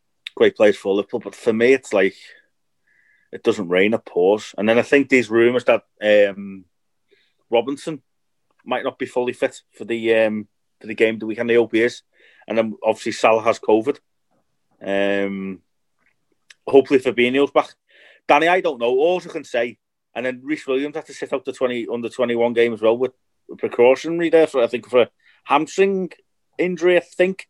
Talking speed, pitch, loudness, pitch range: 185 wpm, 125 Hz, -19 LUFS, 110-155 Hz